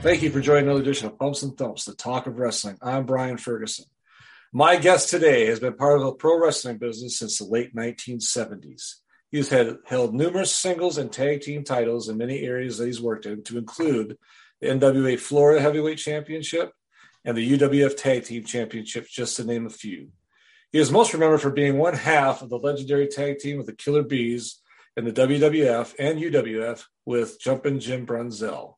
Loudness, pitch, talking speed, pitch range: -23 LUFS, 130 Hz, 190 wpm, 120-145 Hz